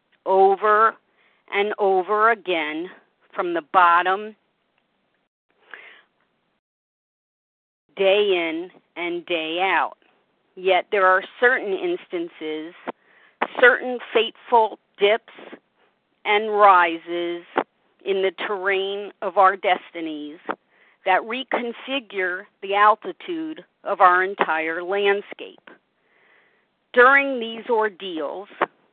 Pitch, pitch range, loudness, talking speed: 200 Hz, 180-225 Hz, -21 LUFS, 80 wpm